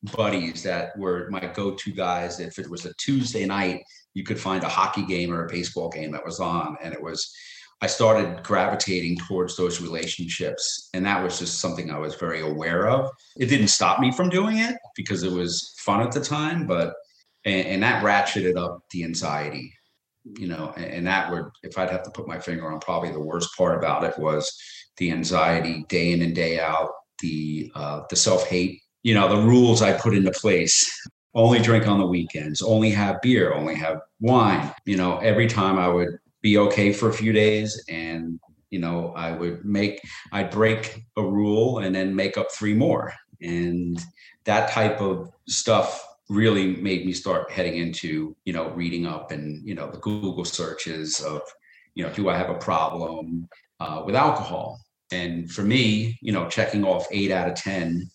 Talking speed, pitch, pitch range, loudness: 195 wpm, 95 Hz, 85-105 Hz, -24 LUFS